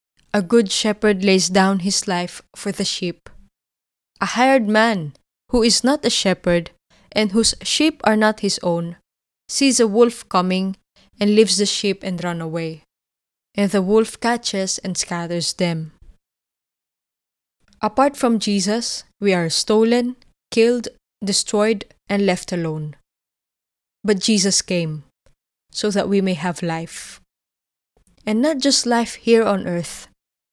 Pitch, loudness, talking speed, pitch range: 200 Hz, -19 LUFS, 140 wpm, 170-220 Hz